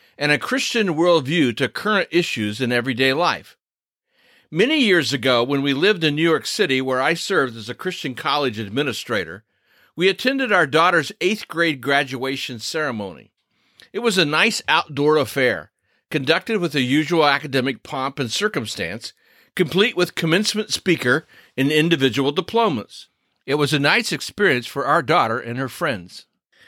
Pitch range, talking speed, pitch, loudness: 135-180 Hz, 155 wpm, 150 Hz, -19 LUFS